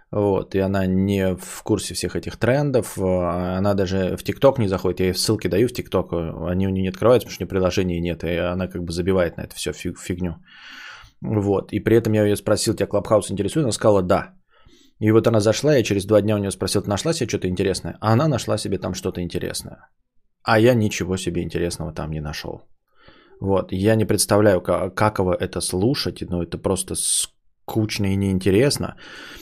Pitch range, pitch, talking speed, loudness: 90-105 Hz, 95 Hz, 205 wpm, -21 LUFS